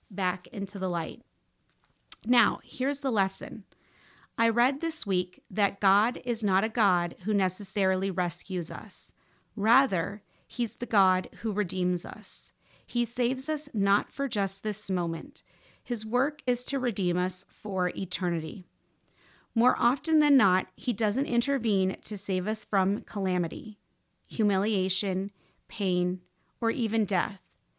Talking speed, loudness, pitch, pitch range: 135 wpm, -27 LUFS, 200 Hz, 185-240 Hz